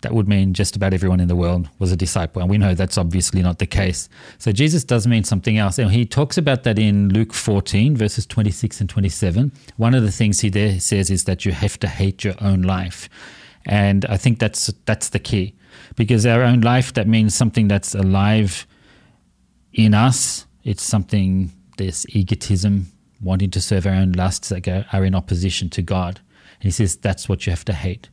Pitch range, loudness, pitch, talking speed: 95-110 Hz, -18 LUFS, 100 Hz, 210 wpm